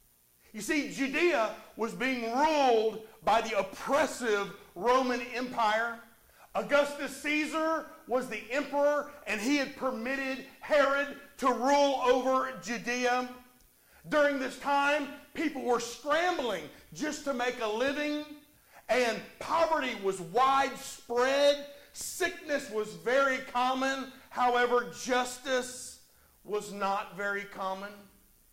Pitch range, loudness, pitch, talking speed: 225-285 Hz, -30 LUFS, 260 Hz, 105 wpm